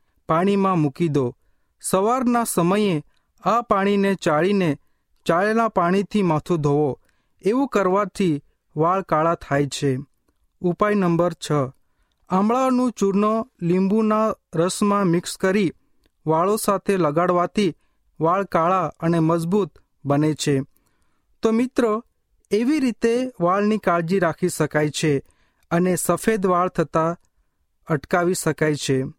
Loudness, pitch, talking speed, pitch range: -21 LUFS, 175 Hz, 105 wpm, 155-205 Hz